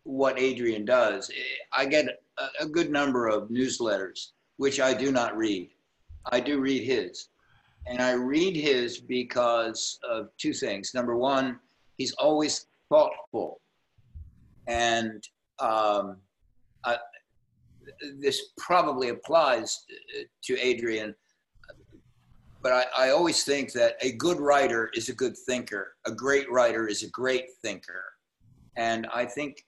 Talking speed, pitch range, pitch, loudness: 130 wpm, 115-145 Hz, 125 Hz, -27 LUFS